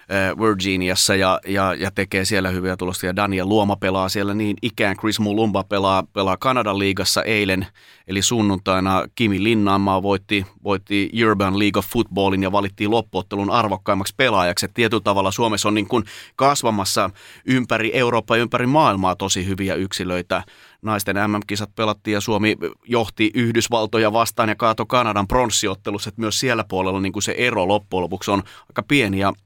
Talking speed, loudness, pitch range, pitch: 155 wpm, -20 LUFS, 95-110 Hz, 100 Hz